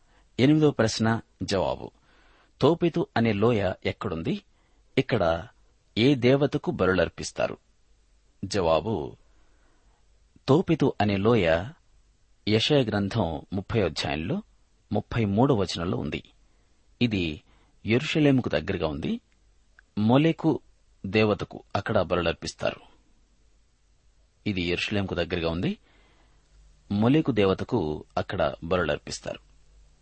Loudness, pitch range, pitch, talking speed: -26 LUFS, 100-135 Hz, 110 Hz, 70 wpm